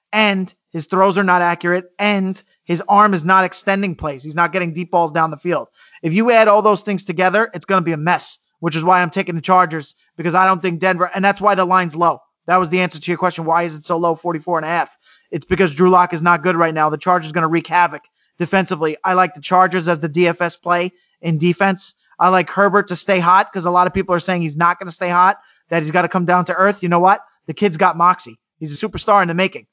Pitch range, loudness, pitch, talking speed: 170-190 Hz, -16 LUFS, 180 Hz, 275 wpm